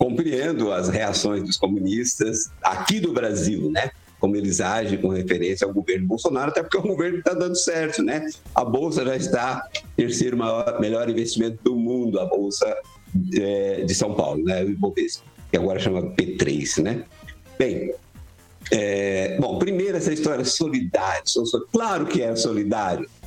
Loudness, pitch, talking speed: -23 LUFS, 115 Hz, 160 wpm